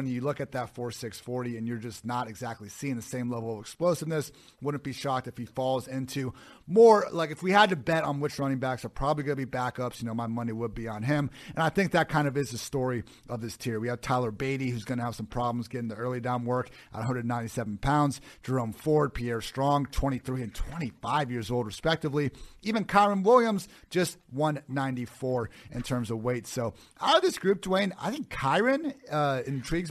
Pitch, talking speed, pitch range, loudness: 130 Hz, 215 wpm, 120-150 Hz, -29 LUFS